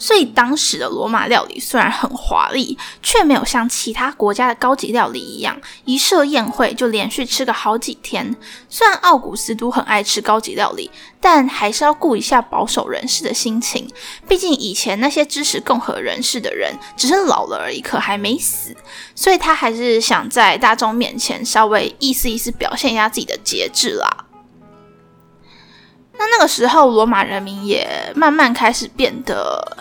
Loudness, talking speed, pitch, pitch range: -16 LUFS, 270 characters per minute, 250 Hz, 220-290 Hz